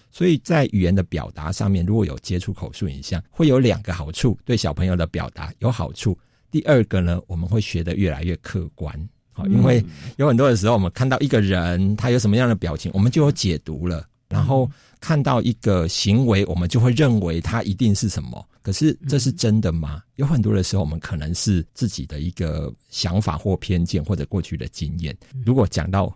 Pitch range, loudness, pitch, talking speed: 85-120 Hz, -21 LUFS, 100 Hz, 315 characters per minute